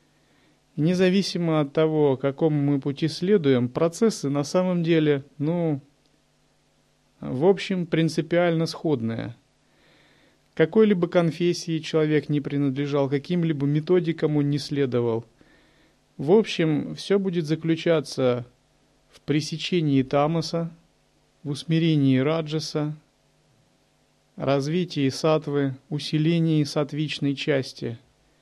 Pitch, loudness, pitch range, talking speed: 155 Hz, -24 LUFS, 140-165 Hz, 90 wpm